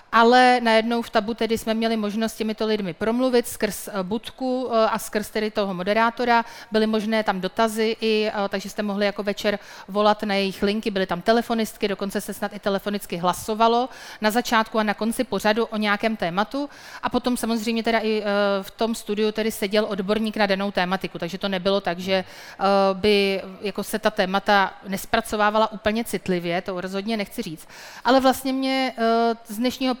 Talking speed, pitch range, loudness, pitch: 175 wpm, 200-230 Hz, -23 LUFS, 215 Hz